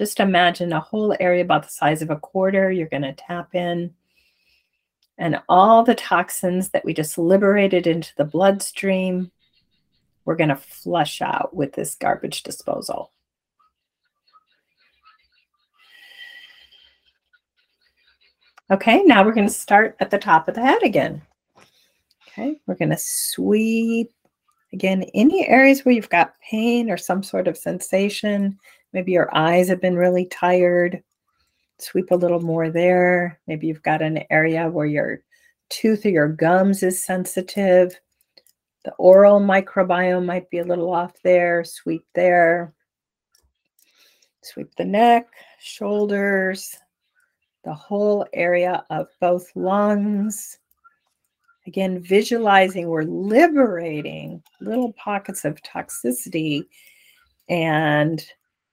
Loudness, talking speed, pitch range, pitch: -19 LUFS, 120 wpm, 175-220 Hz, 185 Hz